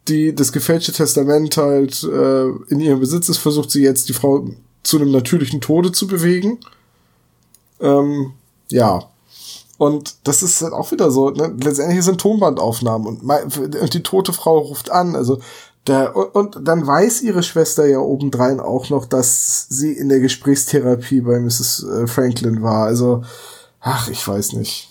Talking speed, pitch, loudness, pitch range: 155 wpm, 140 Hz, -16 LUFS, 130-160 Hz